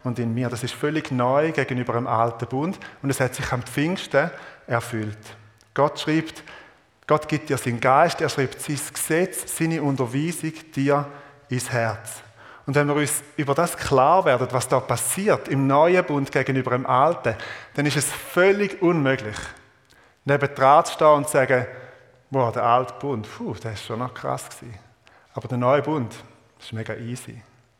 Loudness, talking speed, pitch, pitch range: -22 LUFS, 175 wpm, 135 Hz, 120-150 Hz